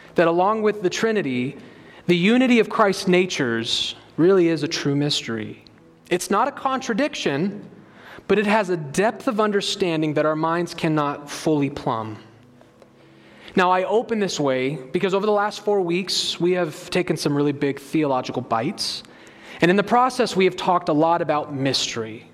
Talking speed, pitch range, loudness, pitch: 165 wpm, 135-195 Hz, -21 LUFS, 170 Hz